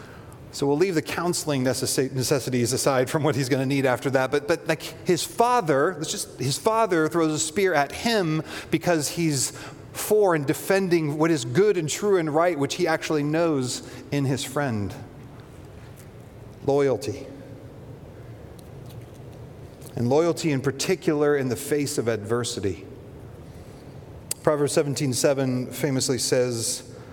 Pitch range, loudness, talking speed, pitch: 130-160 Hz, -24 LUFS, 135 wpm, 140 Hz